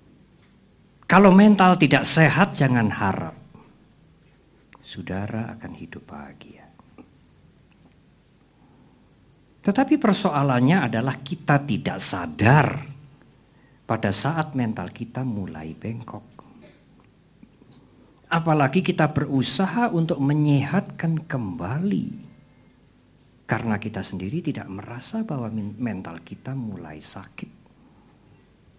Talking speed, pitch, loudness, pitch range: 80 wpm, 135 Hz, -22 LUFS, 110-160 Hz